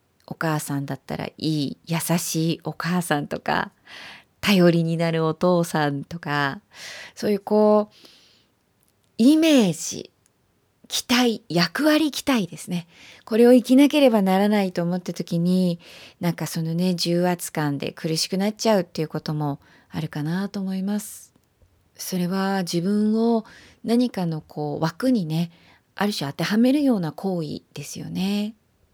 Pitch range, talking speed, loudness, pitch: 160-210 Hz, 275 characters per minute, -22 LUFS, 180 Hz